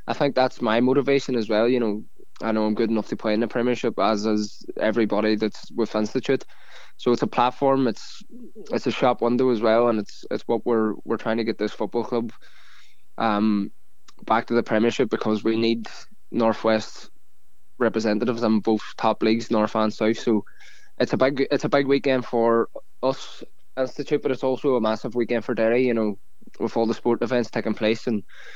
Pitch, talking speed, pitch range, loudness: 115 Hz, 200 wpm, 110-125 Hz, -23 LUFS